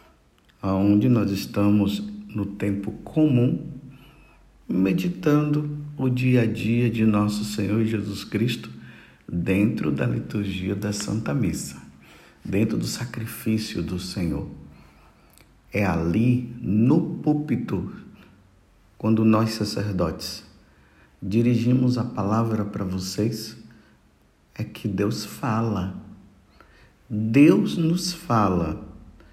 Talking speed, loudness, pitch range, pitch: 95 wpm, -24 LUFS, 100-120 Hz, 110 Hz